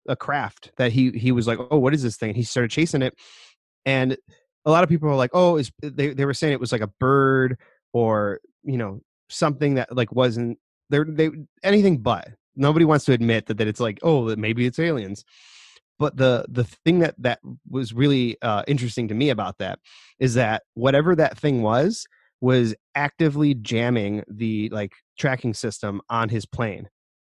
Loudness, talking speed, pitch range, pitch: -22 LUFS, 190 wpm, 115-145 Hz, 125 Hz